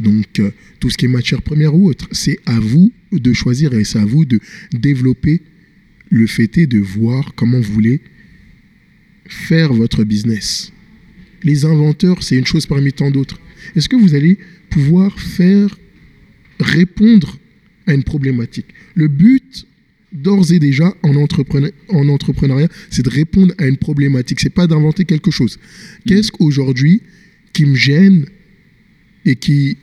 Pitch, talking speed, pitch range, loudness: 155 Hz, 155 wpm, 135-190 Hz, -13 LUFS